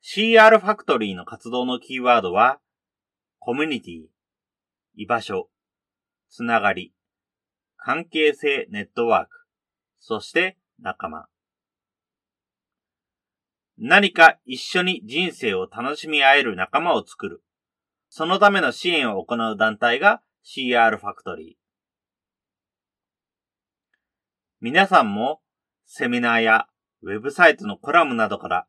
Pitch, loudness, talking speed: 125 Hz, -19 LUFS, 225 characters per minute